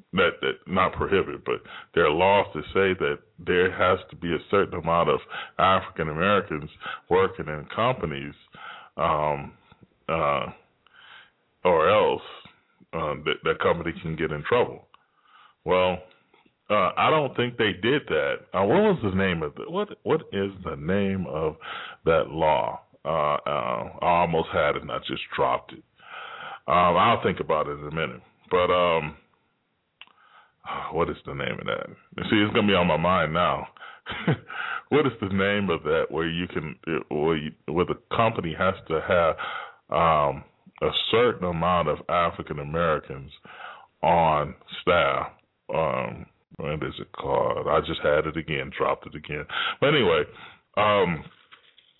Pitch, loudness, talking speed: 95 Hz, -25 LUFS, 155 wpm